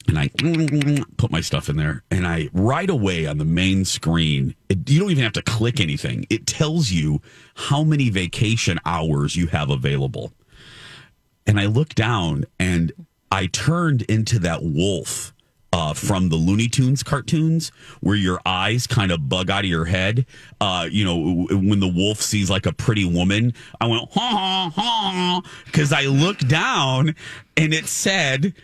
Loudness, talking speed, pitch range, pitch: -20 LUFS, 170 wpm, 90-150 Hz, 115 Hz